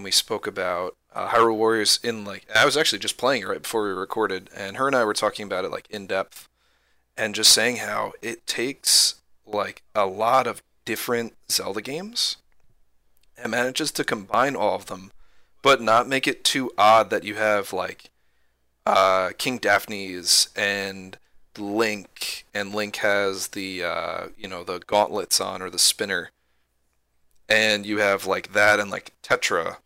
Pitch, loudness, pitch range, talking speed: 100 Hz, -22 LUFS, 90-105 Hz, 170 wpm